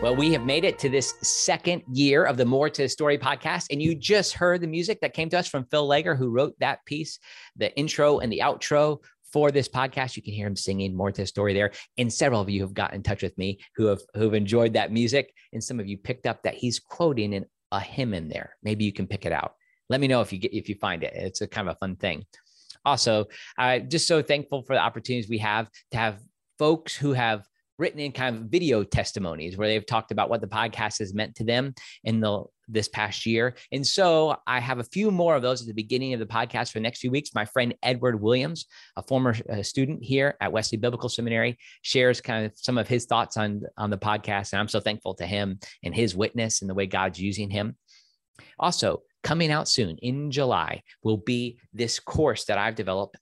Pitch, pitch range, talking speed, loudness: 115 Hz, 105-140 Hz, 240 wpm, -26 LUFS